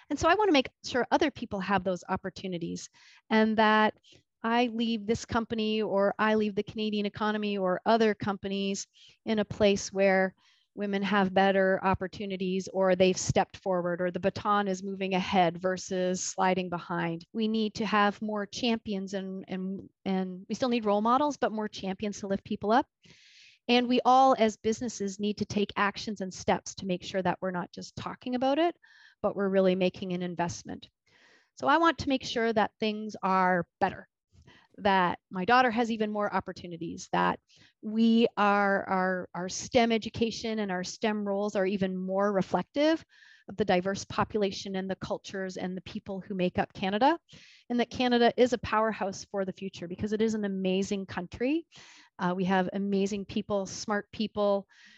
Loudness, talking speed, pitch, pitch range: -29 LUFS, 180 wpm, 200 Hz, 190-220 Hz